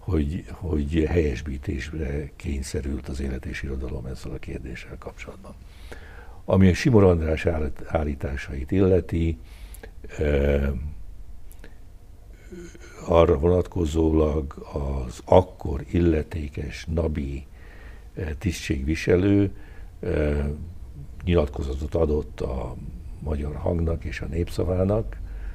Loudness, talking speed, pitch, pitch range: -25 LUFS, 80 wpm, 80 Hz, 75-90 Hz